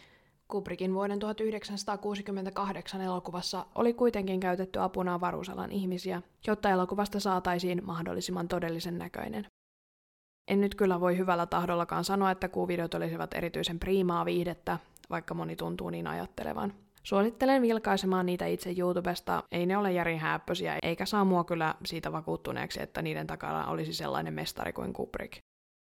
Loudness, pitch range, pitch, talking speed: -32 LUFS, 170-195 Hz, 180 Hz, 130 wpm